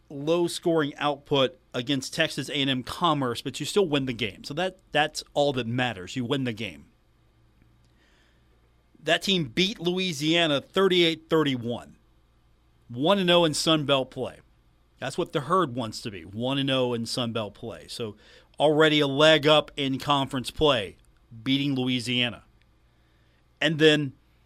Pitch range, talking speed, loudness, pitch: 120-155 Hz, 130 wpm, -25 LUFS, 140 Hz